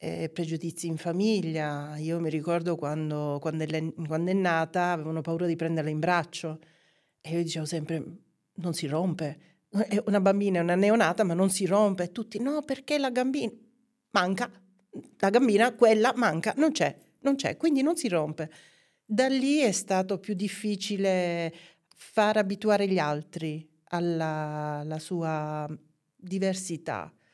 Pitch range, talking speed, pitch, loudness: 160-210 Hz, 145 wpm, 175 Hz, -28 LUFS